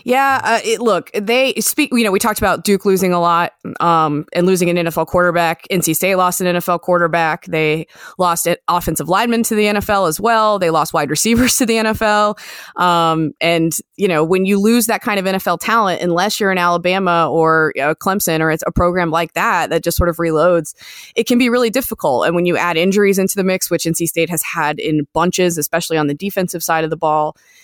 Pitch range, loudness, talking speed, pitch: 165-210 Hz, -15 LUFS, 220 wpm, 175 Hz